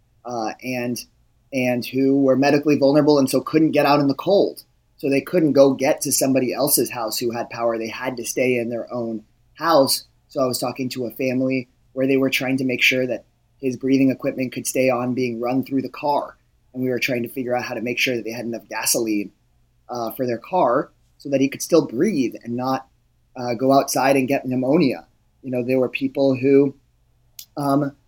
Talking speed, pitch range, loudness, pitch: 220 wpm, 120-135 Hz, -20 LUFS, 130 Hz